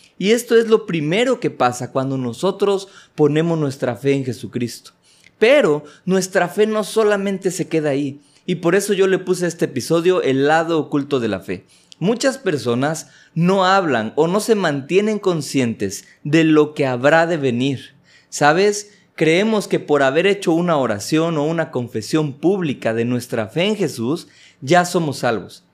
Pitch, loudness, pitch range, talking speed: 160 Hz, -18 LUFS, 135-190 Hz, 170 wpm